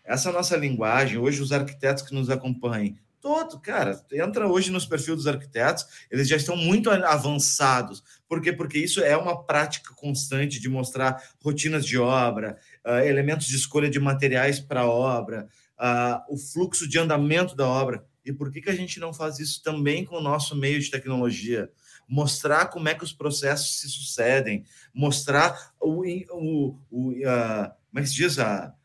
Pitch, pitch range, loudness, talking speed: 140 Hz, 130-155 Hz, -25 LUFS, 170 wpm